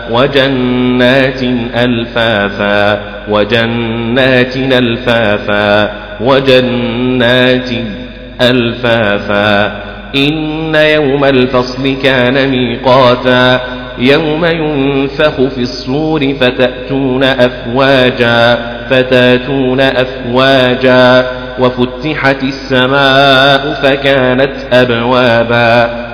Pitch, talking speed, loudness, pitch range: 125 Hz, 55 wpm, -9 LUFS, 120-135 Hz